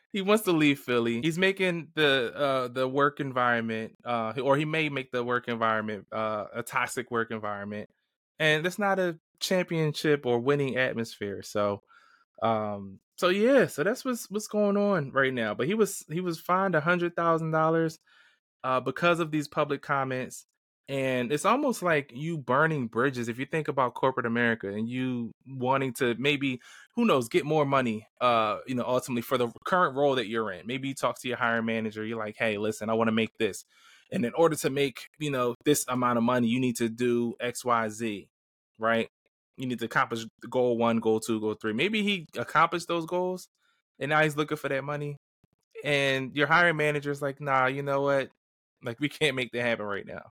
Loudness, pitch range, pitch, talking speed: -28 LUFS, 115-155 Hz, 135 Hz, 205 wpm